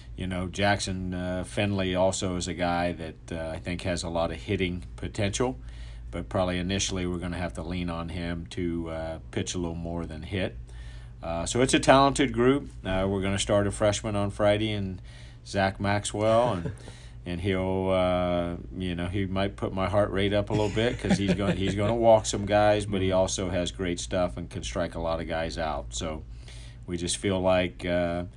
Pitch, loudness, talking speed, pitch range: 95 Hz, -27 LUFS, 215 wpm, 85-100 Hz